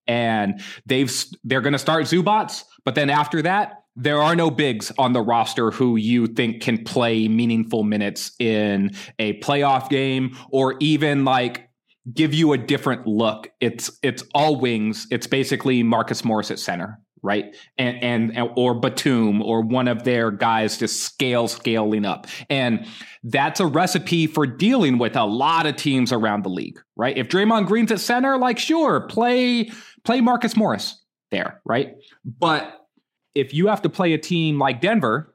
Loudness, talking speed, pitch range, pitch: -21 LUFS, 170 wpm, 115-160 Hz, 130 Hz